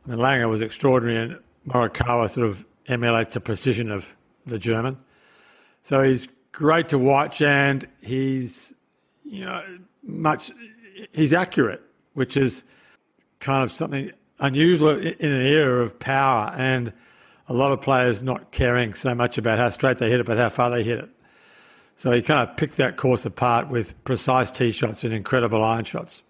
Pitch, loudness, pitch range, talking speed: 130 Hz, -22 LUFS, 120-140 Hz, 170 wpm